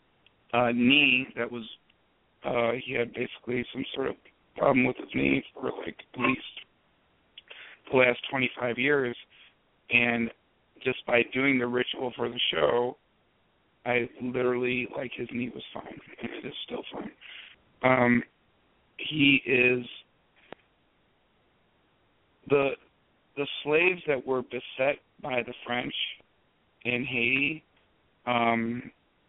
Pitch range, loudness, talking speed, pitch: 120-130 Hz, -27 LUFS, 125 wpm, 125 Hz